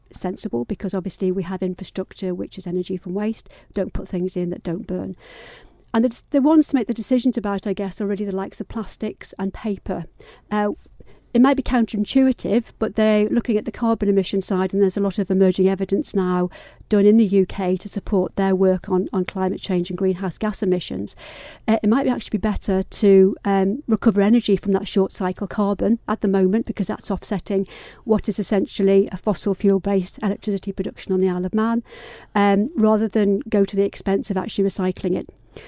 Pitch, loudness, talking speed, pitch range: 200 Hz, -21 LUFS, 200 wpm, 190-215 Hz